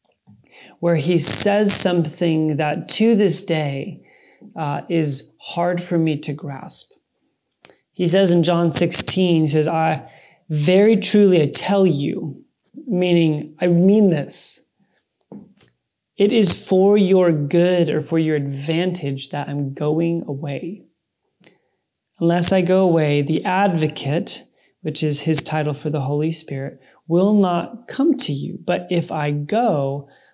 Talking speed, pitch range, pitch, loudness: 135 wpm, 150-185 Hz, 170 Hz, -18 LUFS